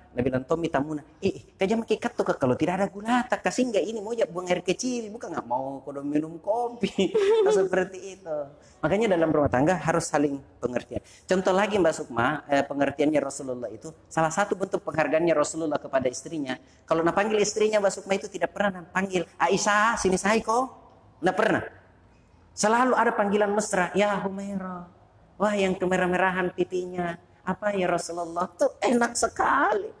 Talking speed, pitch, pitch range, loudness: 160 wpm, 185 Hz, 160-205 Hz, -26 LUFS